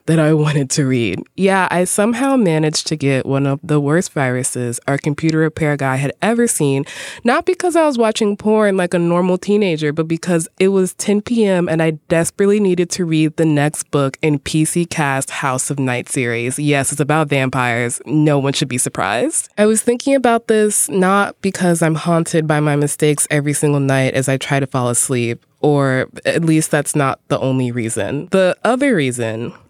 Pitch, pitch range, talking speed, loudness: 155 Hz, 140-185 Hz, 195 wpm, -16 LUFS